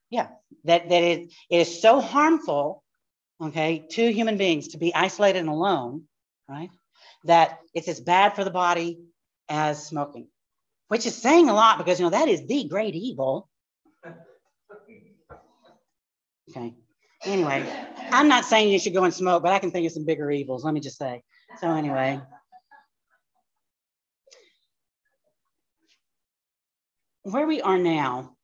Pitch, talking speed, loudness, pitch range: 175 Hz, 145 wpm, -23 LUFS, 150-225 Hz